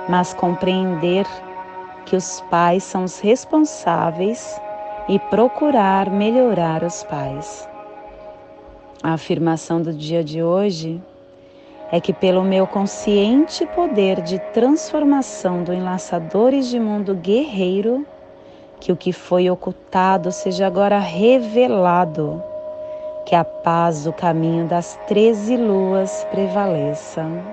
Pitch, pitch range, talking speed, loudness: 190 Hz, 175-210 Hz, 105 wpm, -18 LUFS